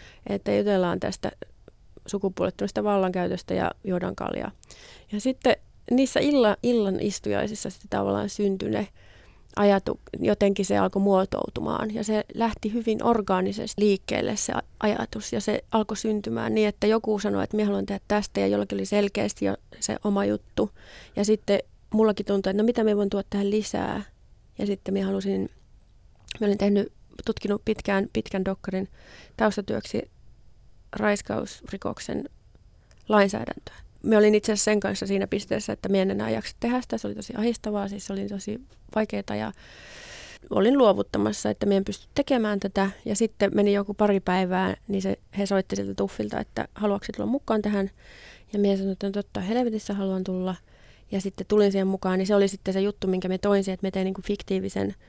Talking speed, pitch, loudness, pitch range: 165 wpm, 200 Hz, -26 LUFS, 185-210 Hz